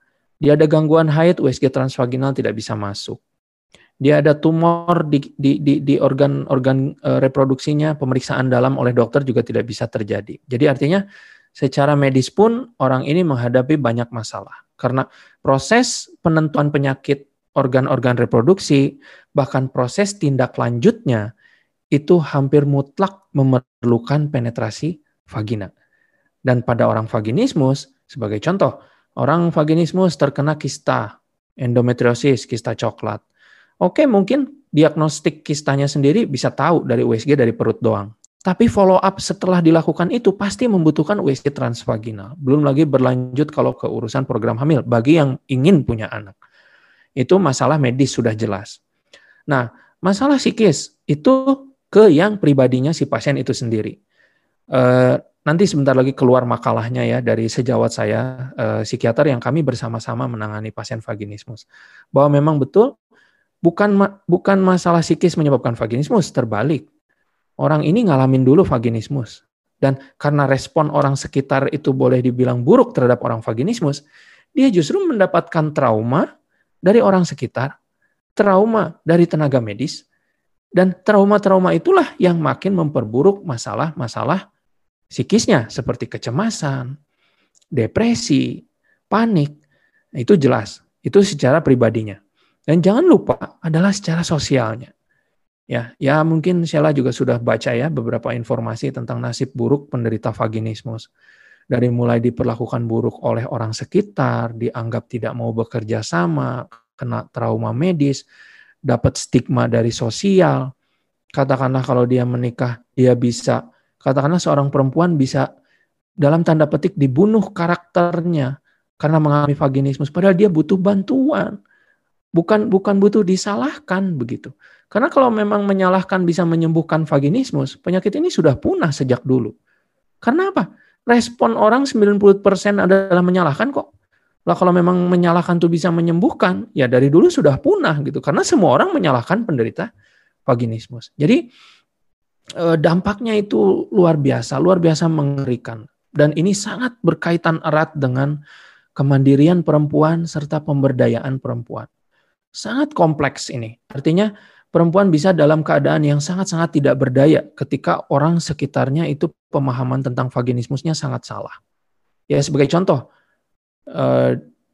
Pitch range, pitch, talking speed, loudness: 125-175 Hz, 145 Hz, 125 wpm, -17 LUFS